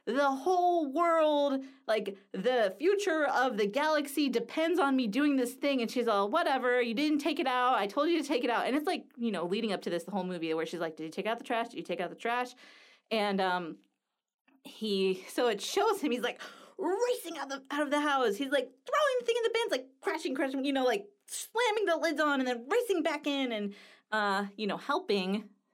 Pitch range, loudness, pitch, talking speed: 220-310 Hz, -31 LUFS, 270 Hz, 240 wpm